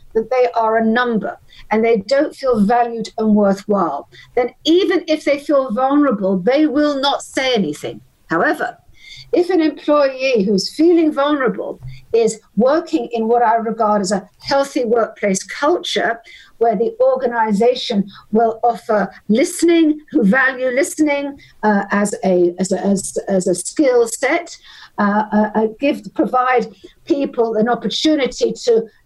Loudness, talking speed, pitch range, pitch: -16 LUFS, 140 wpm, 210-280 Hz, 240 Hz